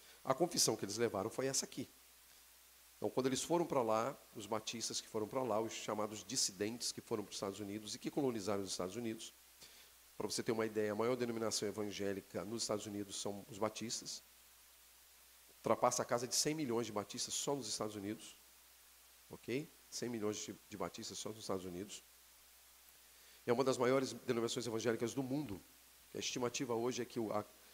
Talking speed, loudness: 185 wpm, -40 LUFS